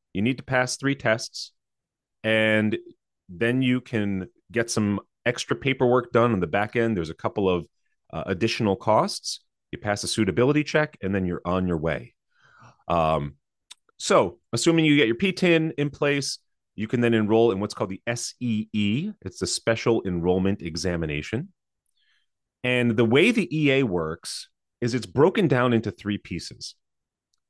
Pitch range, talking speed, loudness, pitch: 95-130 Hz, 160 wpm, -24 LUFS, 115 Hz